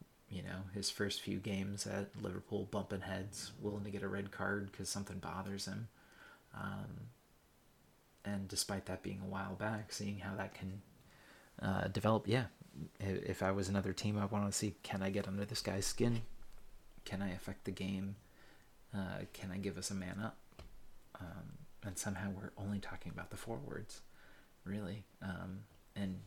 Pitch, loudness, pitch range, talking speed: 100 Hz, -42 LUFS, 95-100 Hz, 175 wpm